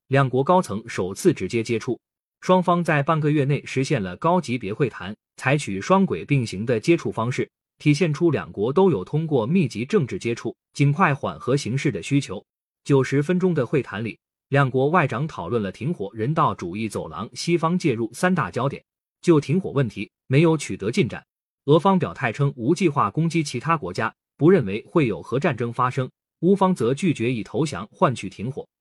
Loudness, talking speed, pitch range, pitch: -22 LUFS, 285 characters per minute, 120-170 Hz, 145 Hz